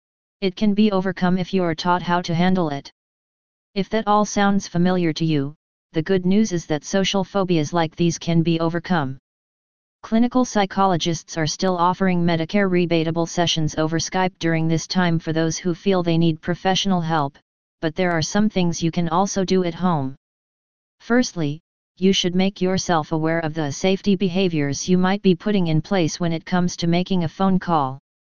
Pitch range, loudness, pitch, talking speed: 165-190 Hz, -21 LUFS, 175 Hz, 185 wpm